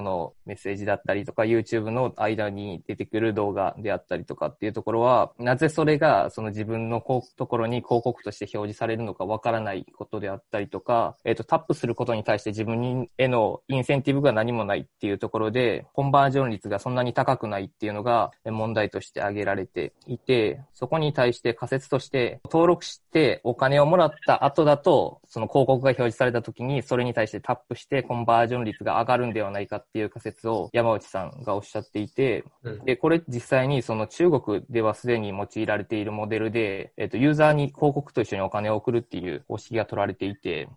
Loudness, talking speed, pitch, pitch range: -25 LUFS, 330 characters per minute, 115 Hz, 105-130 Hz